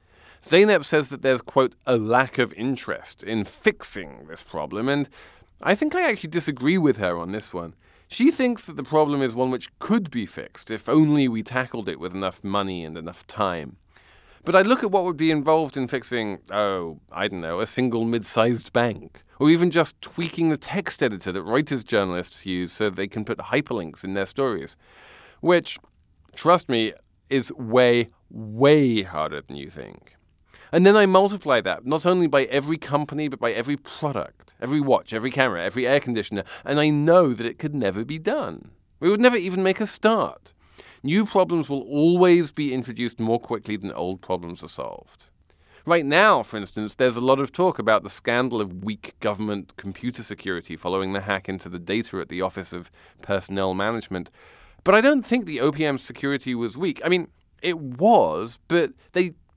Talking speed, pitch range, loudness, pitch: 190 wpm, 100-155 Hz, -23 LUFS, 125 Hz